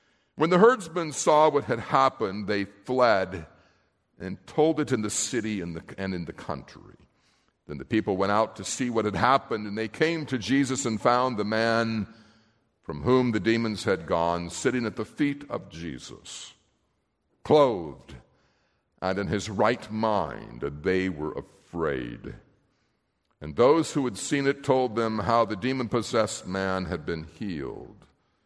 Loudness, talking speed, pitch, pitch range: -26 LUFS, 160 wpm, 110 Hz, 95-130 Hz